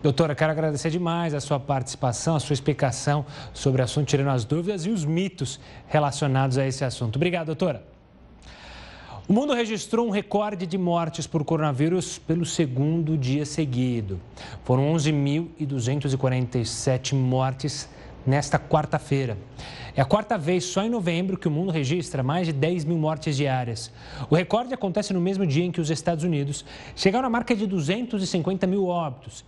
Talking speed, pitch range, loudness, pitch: 160 wpm, 135-175 Hz, -25 LUFS, 155 Hz